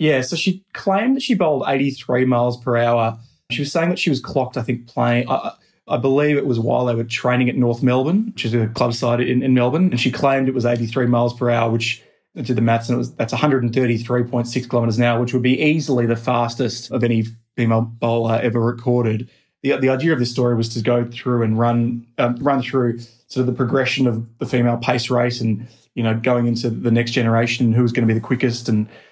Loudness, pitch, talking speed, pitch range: -19 LUFS, 120 Hz, 250 wpm, 120-130 Hz